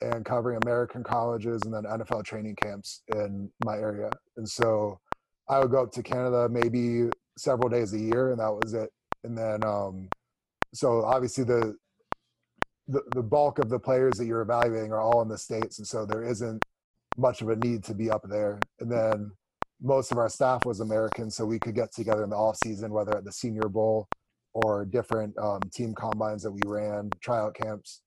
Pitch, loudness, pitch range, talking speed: 110 Hz, -29 LUFS, 105-120 Hz, 200 wpm